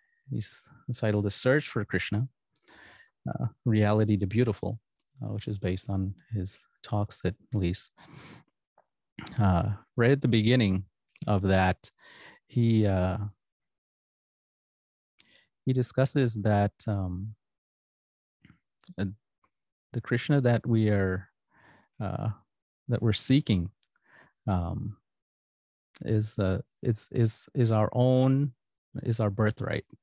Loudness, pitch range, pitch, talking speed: -28 LUFS, 100-120 Hz, 105 Hz, 105 wpm